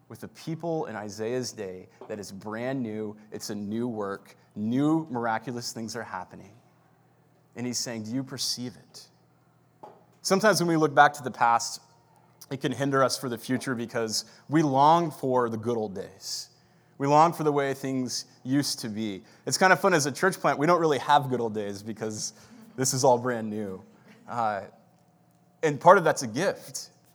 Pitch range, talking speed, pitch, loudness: 110-145 Hz, 190 wpm, 125 Hz, -26 LUFS